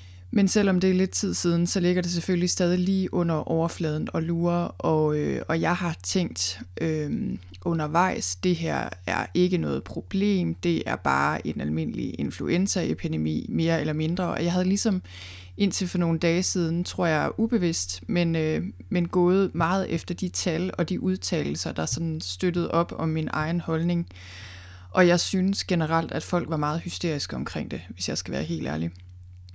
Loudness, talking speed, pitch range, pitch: -26 LUFS, 180 wpm, 150-180 Hz, 170 Hz